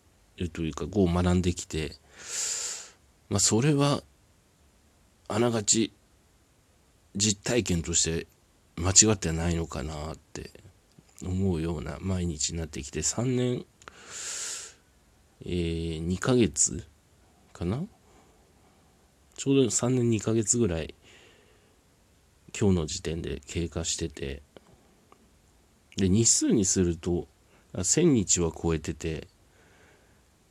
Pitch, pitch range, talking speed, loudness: 90 Hz, 80-100 Hz, 180 characters per minute, -27 LUFS